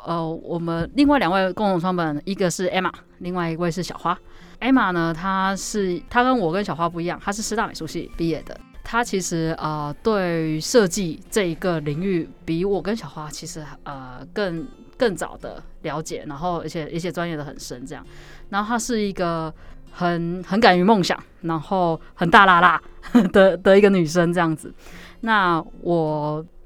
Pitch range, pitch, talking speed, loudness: 165-195 Hz, 175 Hz, 270 characters per minute, -21 LUFS